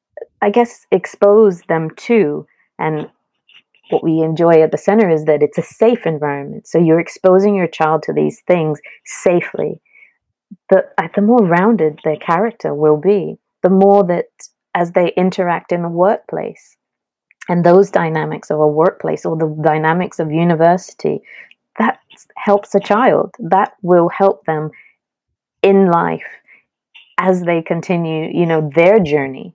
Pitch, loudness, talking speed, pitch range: 175 Hz, -14 LUFS, 145 wpm, 160-200 Hz